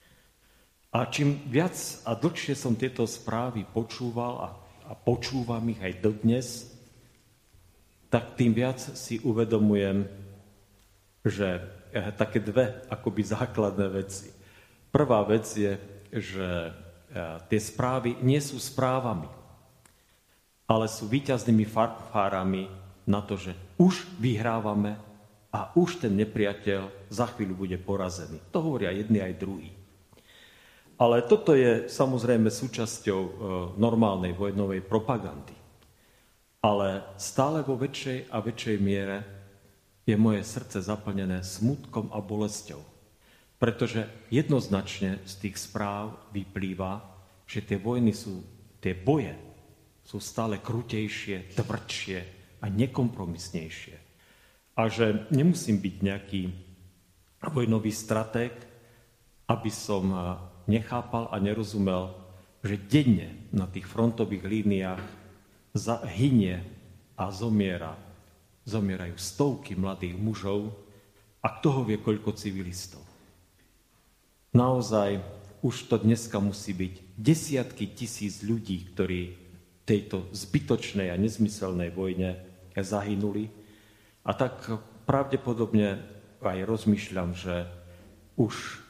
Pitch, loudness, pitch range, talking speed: 105 Hz, -29 LUFS, 95-115 Hz, 100 wpm